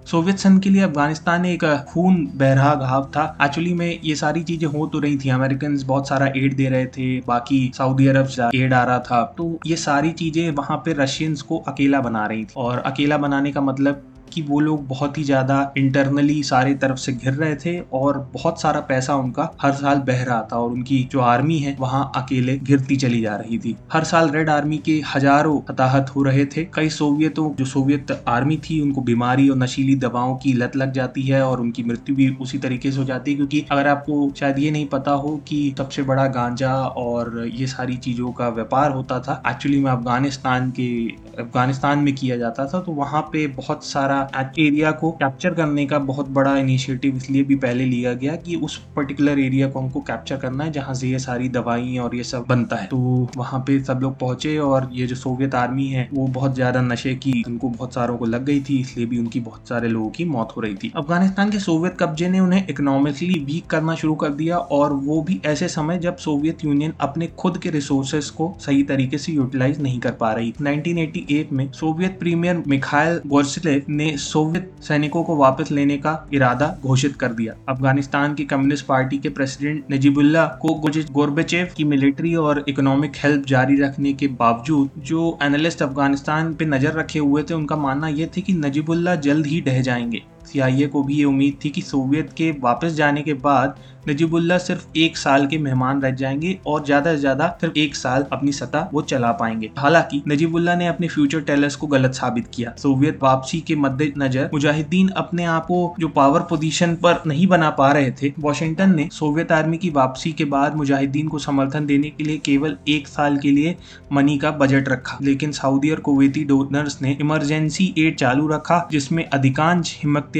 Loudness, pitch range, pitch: -20 LUFS, 135-155 Hz, 140 Hz